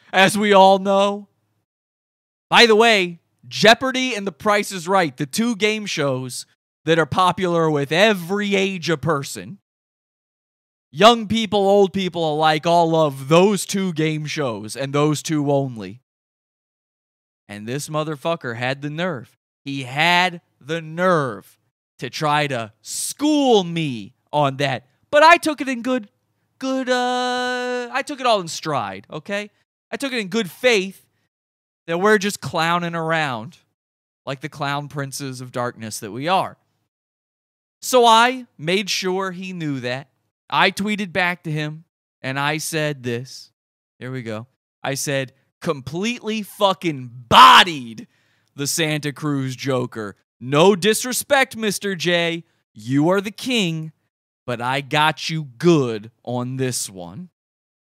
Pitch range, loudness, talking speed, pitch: 135-200 Hz, -19 LUFS, 140 wpm, 160 Hz